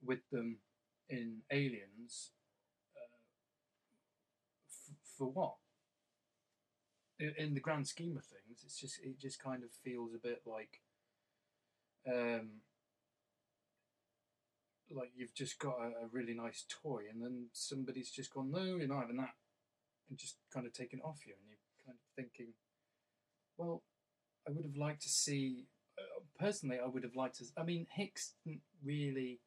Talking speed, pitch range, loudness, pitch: 155 wpm, 120-145 Hz, -44 LUFS, 130 Hz